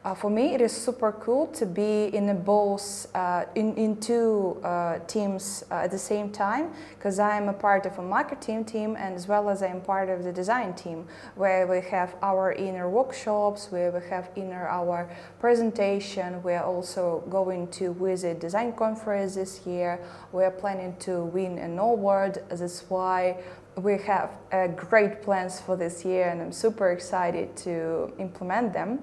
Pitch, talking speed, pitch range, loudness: 190 Hz, 185 wpm, 180-210 Hz, -27 LUFS